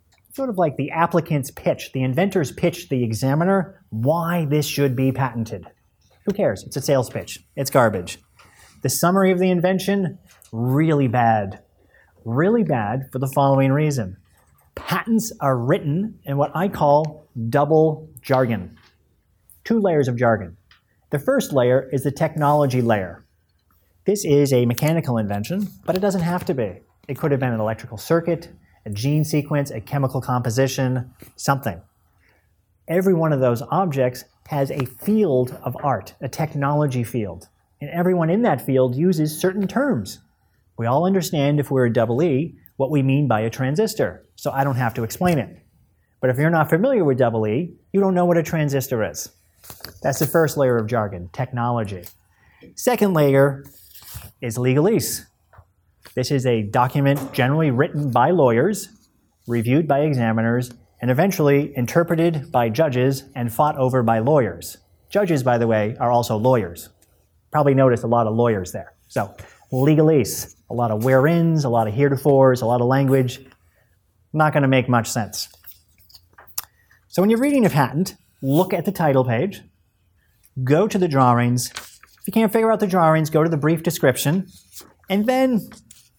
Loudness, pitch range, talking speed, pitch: -20 LUFS, 115-155 Hz, 165 wpm, 135 Hz